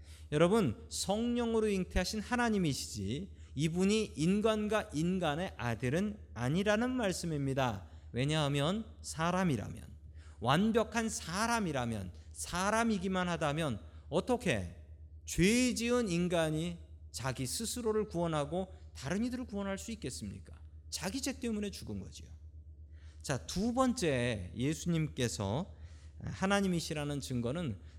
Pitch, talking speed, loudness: 155 Hz, 270 characters per minute, -34 LUFS